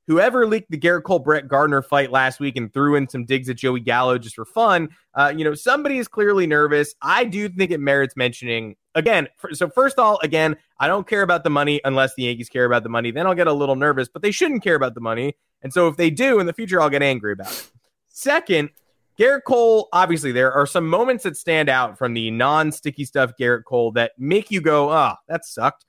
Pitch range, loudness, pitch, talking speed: 130-180 Hz, -19 LUFS, 150 Hz, 245 wpm